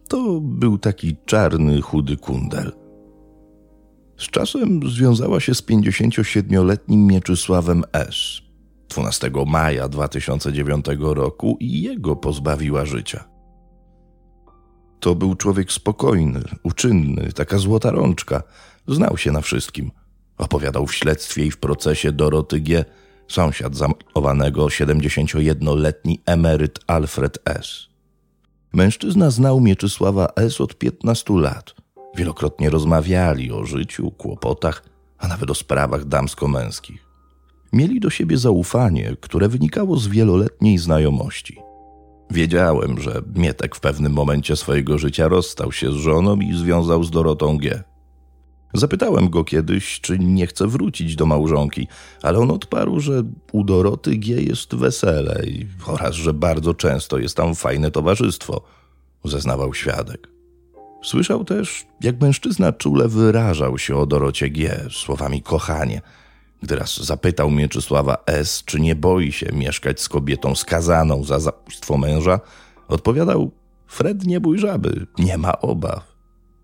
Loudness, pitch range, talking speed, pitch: -19 LUFS, 70-100 Hz, 120 wpm, 80 Hz